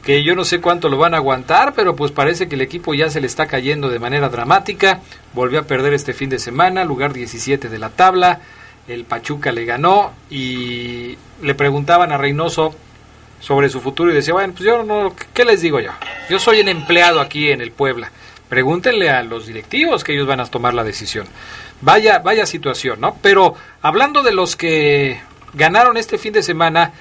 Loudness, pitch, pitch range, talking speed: -15 LUFS, 145 Hz, 125-180 Hz, 200 wpm